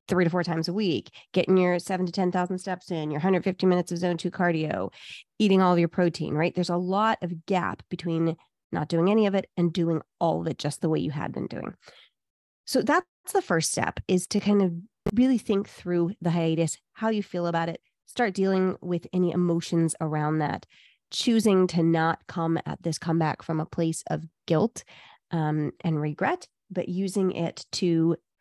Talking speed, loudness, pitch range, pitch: 200 wpm, -26 LUFS, 165-190 Hz, 175 Hz